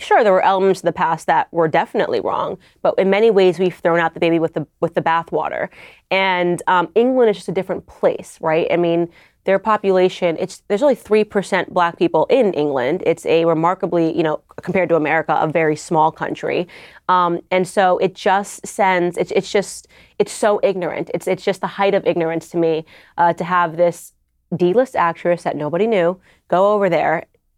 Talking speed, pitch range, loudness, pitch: 195 wpm, 170-190 Hz, -18 LUFS, 180 Hz